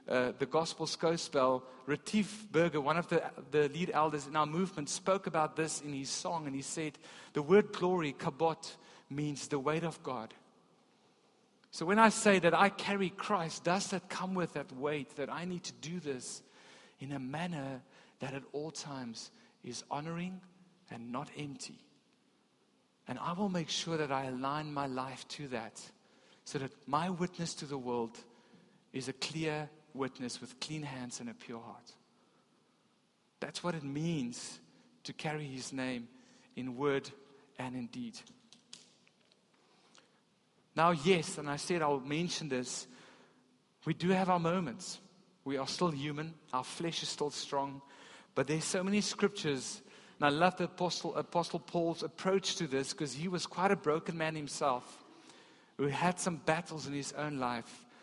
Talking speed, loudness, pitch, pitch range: 170 wpm, -35 LUFS, 155 Hz, 140-180 Hz